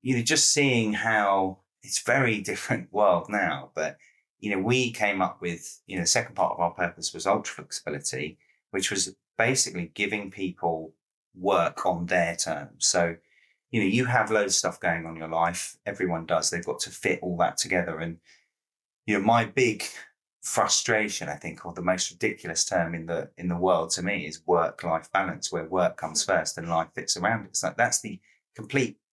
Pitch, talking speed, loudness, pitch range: 90 Hz, 195 wpm, -26 LUFS, 85-100 Hz